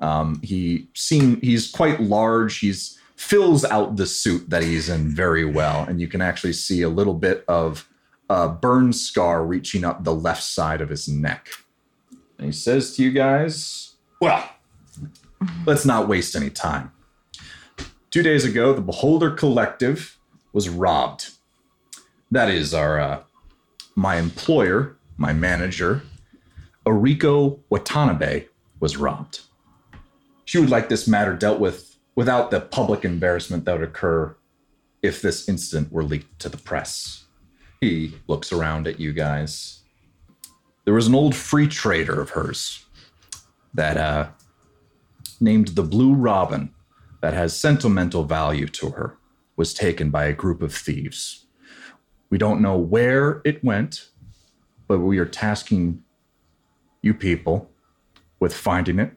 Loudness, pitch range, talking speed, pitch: -21 LUFS, 80-125 Hz, 140 wpm, 90 Hz